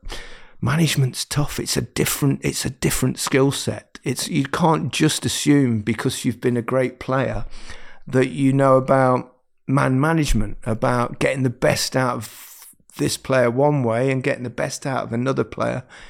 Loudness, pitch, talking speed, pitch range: -20 LUFS, 130 Hz, 170 wpm, 125-140 Hz